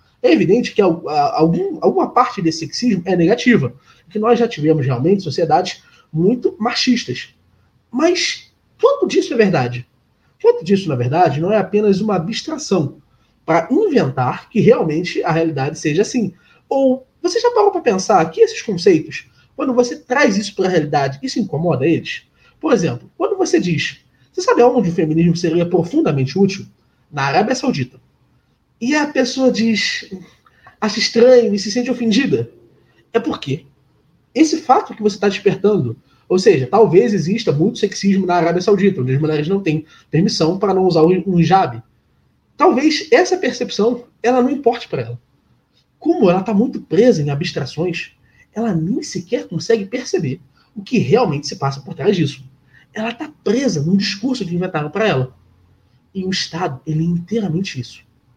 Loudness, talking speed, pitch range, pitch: -16 LUFS, 160 wpm, 160-245 Hz, 200 Hz